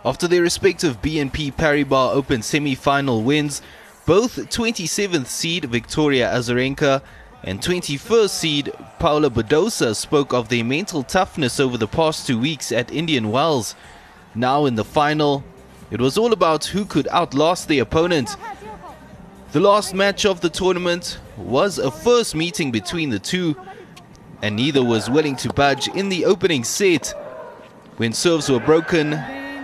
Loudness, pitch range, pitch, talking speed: -19 LUFS, 130-175 Hz, 150 Hz, 145 wpm